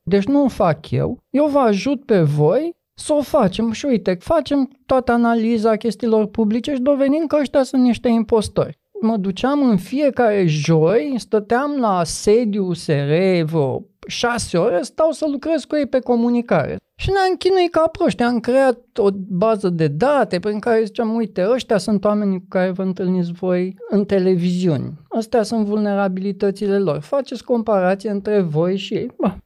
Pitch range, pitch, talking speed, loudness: 195-260 Hz, 225 Hz, 165 wpm, -18 LUFS